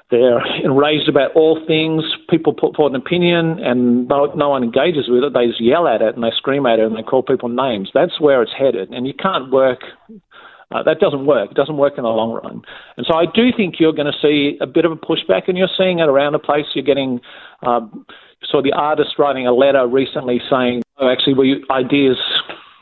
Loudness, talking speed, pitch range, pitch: -16 LUFS, 235 wpm, 125-160 Hz, 140 Hz